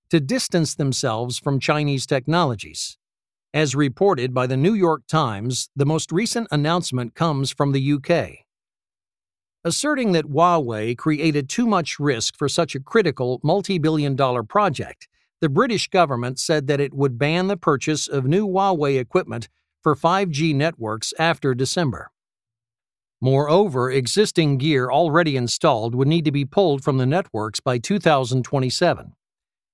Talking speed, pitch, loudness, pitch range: 140 wpm, 145 Hz, -20 LUFS, 130-170 Hz